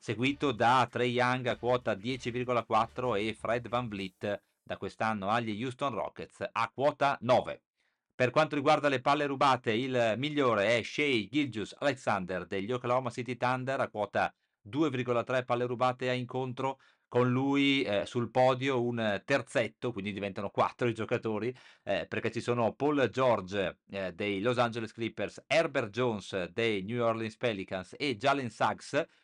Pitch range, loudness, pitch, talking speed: 110-130 Hz, -31 LUFS, 120 Hz, 150 wpm